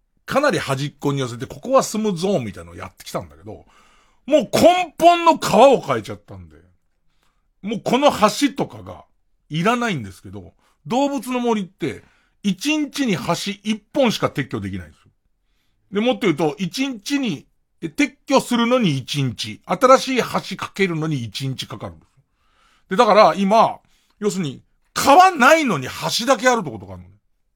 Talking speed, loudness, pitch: 335 characters per minute, -19 LUFS, 185 Hz